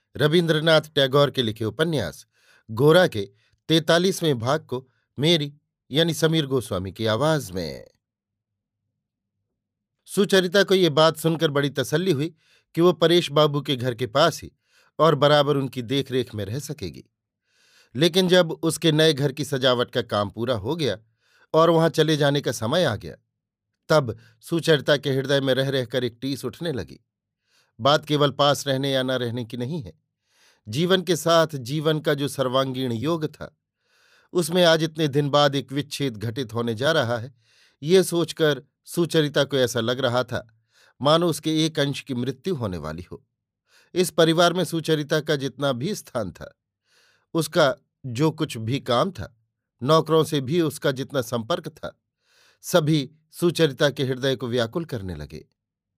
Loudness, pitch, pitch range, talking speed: -22 LUFS, 145 Hz, 125-160 Hz, 160 wpm